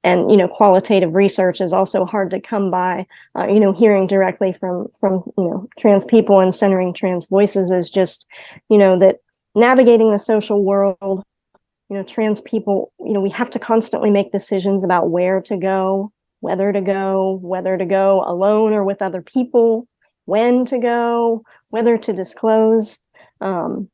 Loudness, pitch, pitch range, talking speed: -16 LUFS, 200 Hz, 190-220 Hz, 175 wpm